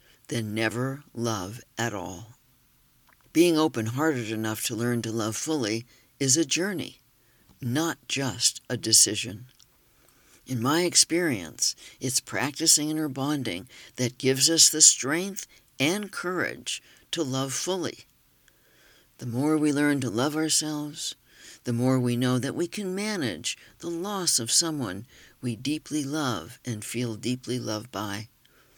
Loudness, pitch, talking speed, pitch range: -25 LUFS, 130 Hz, 135 wpm, 120-155 Hz